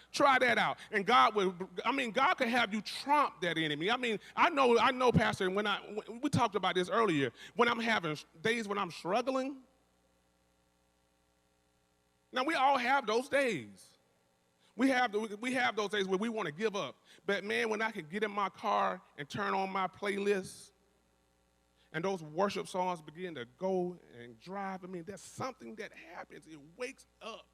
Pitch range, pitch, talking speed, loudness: 150-235 Hz, 200 Hz, 185 wpm, -32 LUFS